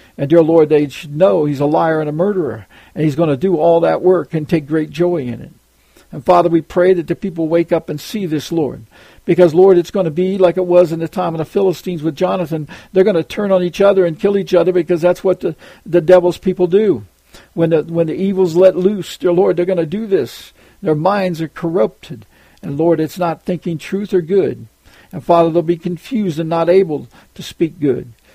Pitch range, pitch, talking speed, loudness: 165-185 Hz, 175 Hz, 235 wpm, -15 LUFS